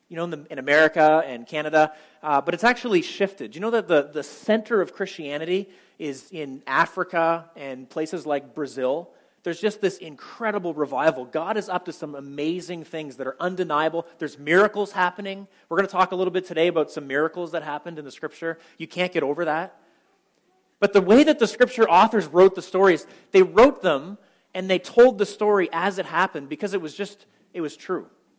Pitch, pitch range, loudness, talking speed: 175 Hz, 155-195 Hz, -22 LUFS, 200 wpm